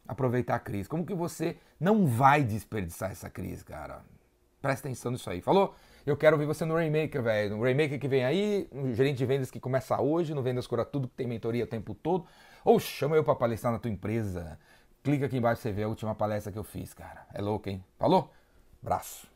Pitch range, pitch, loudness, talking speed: 105-145 Hz, 125 Hz, -30 LUFS, 225 wpm